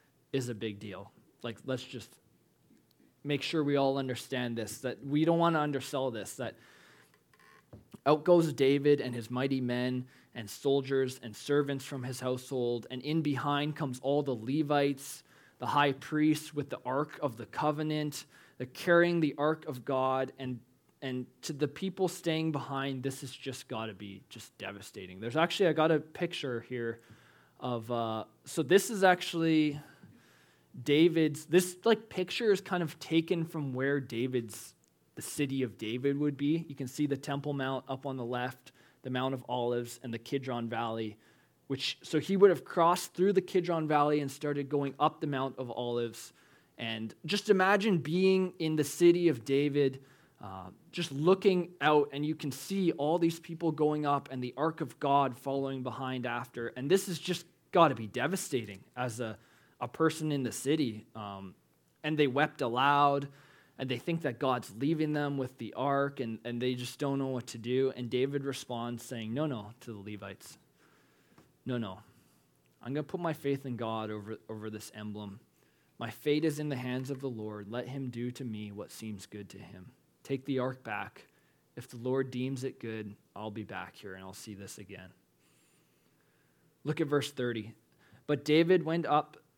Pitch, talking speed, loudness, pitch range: 135 Hz, 185 wpm, -32 LUFS, 120-150 Hz